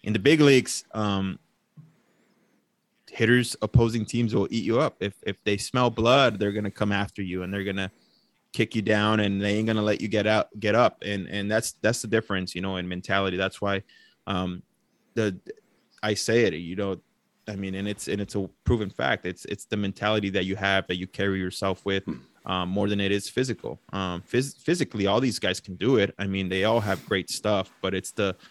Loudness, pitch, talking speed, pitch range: -26 LUFS, 100 Hz, 215 wpm, 95-110 Hz